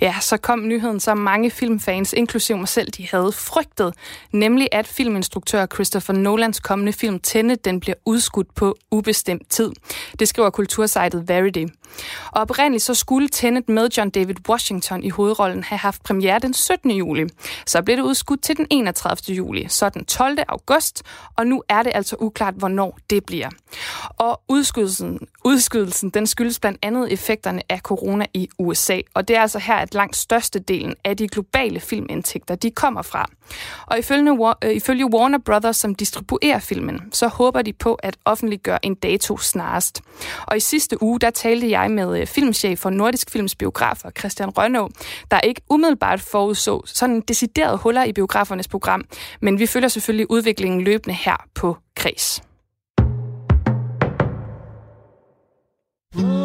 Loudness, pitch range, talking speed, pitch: -19 LUFS, 195-235 Hz, 155 wpm, 210 Hz